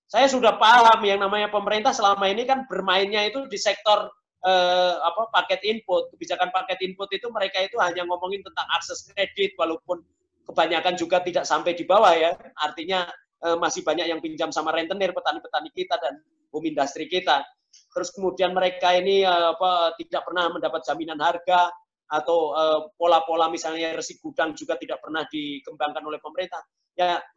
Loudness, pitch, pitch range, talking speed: -23 LUFS, 180 Hz, 165-205 Hz, 160 wpm